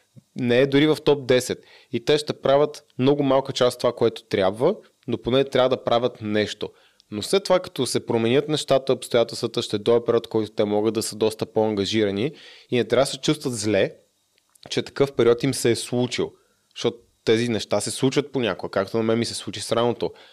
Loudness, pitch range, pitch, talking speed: -23 LUFS, 110-135 Hz, 120 Hz, 205 wpm